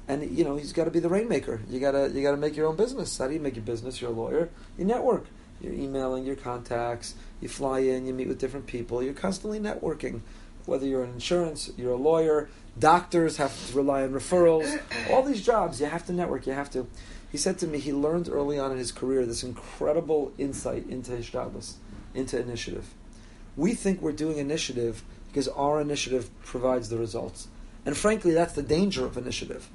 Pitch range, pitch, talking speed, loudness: 125-160 Hz, 140 Hz, 205 wpm, -28 LUFS